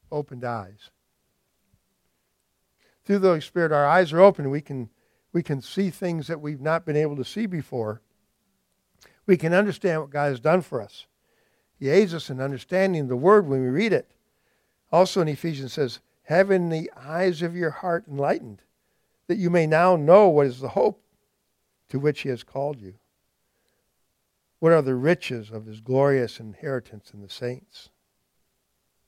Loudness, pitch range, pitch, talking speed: -23 LUFS, 130-175 Hz, 150 Hz, 165 wpm